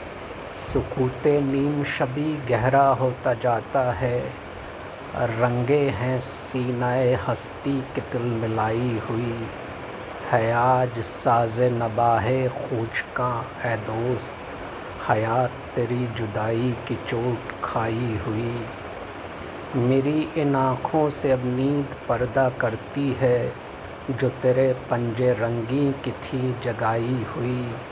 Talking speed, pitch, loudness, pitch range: 95 wpm, 125 Hz, -24 LUFS, 115-130 Hz